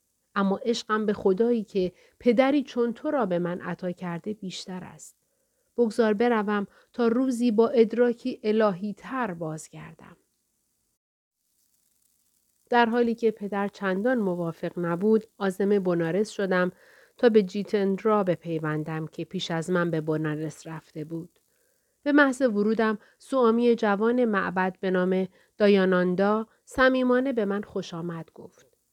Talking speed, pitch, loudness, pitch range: 130 wpm, 205 Hz, -25 LUFS, 180-235 Hz